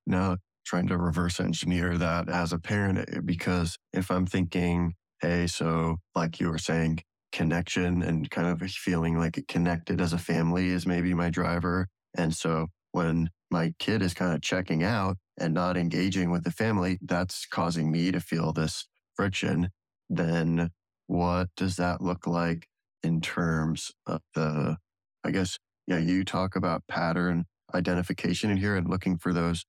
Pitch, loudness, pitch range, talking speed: 85 Hz, -29 LUFS, 85-90 Hz, 165 wpm